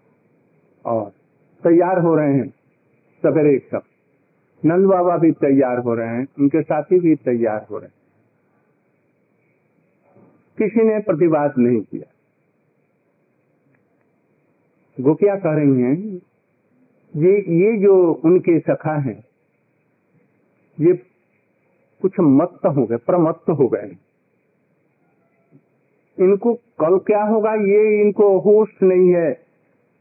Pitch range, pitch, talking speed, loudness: 140-195 Hz, 170 Hz, 105 wpm, -17 LUFS